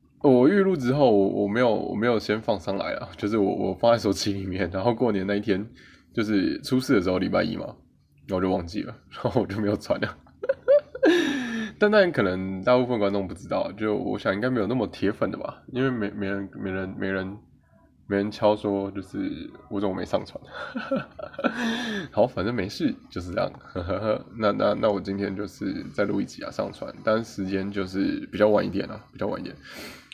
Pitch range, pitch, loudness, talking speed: 100-130 Hz, 105 Hz, -25 LUFS, 290 characters per minute